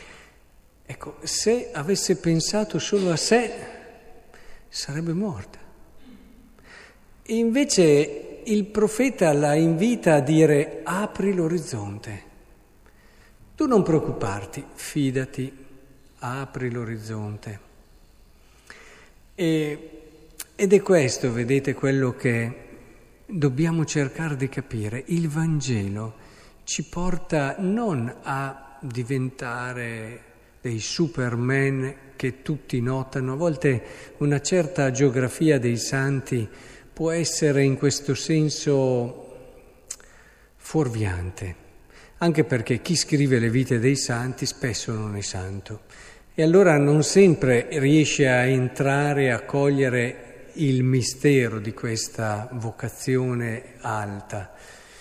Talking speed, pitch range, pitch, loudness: 95 wpm, 120-160 Hz, 135 Hz, -23 LUFS